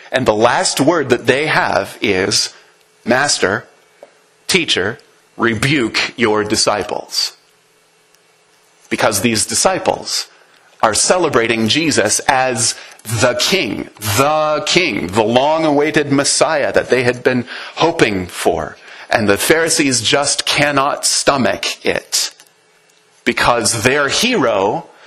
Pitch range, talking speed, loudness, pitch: 115-150 Hz, 105 wpm, -14 LUFS, 130 Hz